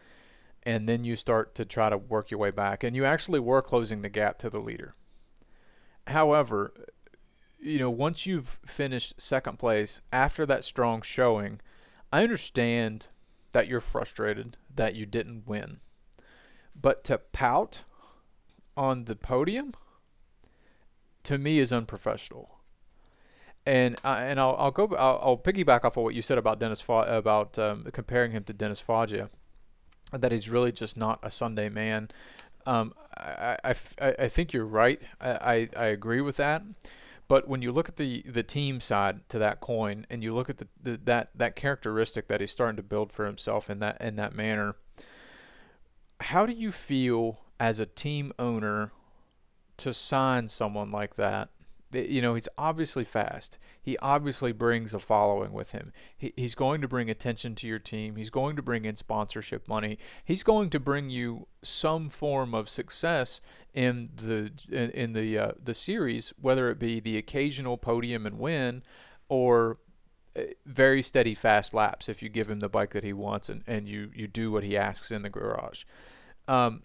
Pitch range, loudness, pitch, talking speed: 110-135 Hz, -29 LUFS, 115 Hz, 175 wpm